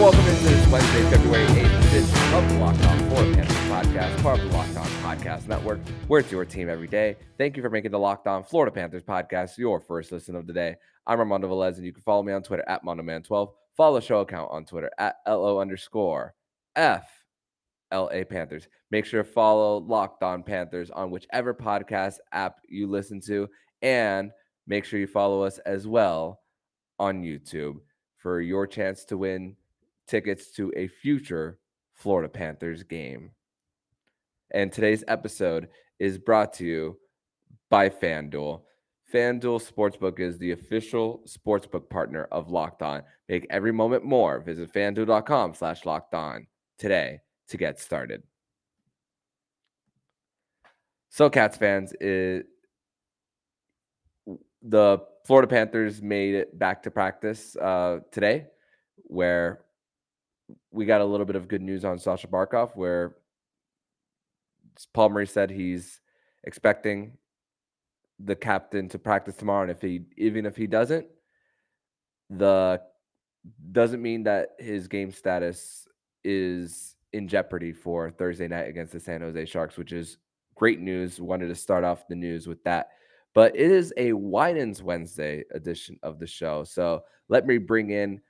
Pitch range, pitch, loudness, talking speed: 85-105 Hz, 95 Hz, -25 LUFS, 150 wpm